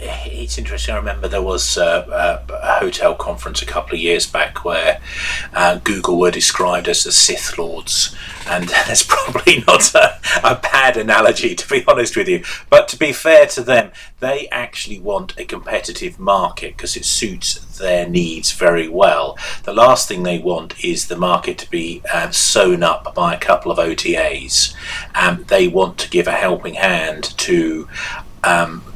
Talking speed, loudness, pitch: 175 wpm, -15 LUFS, 310 Hz